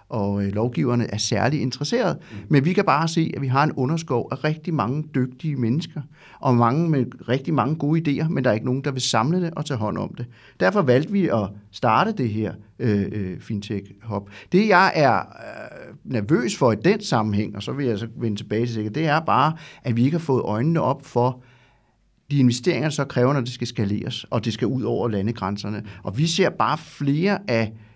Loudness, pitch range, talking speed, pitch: -22 LUFS, 110-150 Hz, 215 wpm, 125 Hz